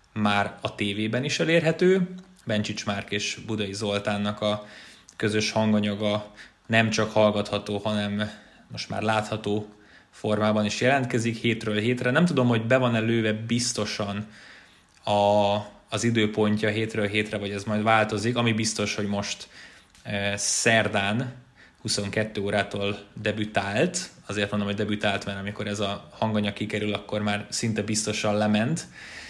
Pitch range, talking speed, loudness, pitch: 105-110 Hz, 135 wpm, -25 LUFS, 105 Hz